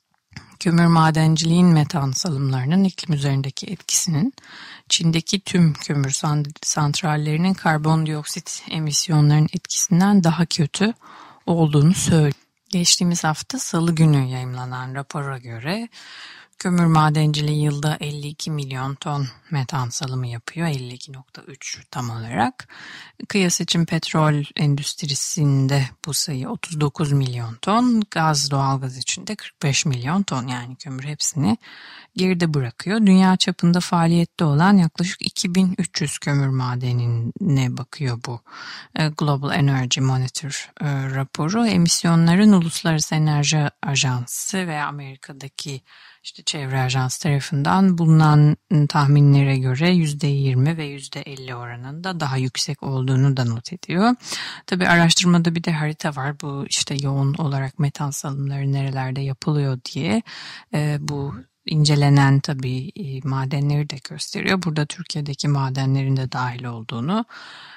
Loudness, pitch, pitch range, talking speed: -20 LUFS, 150 Hz, 135-170 Hz, 110 wpm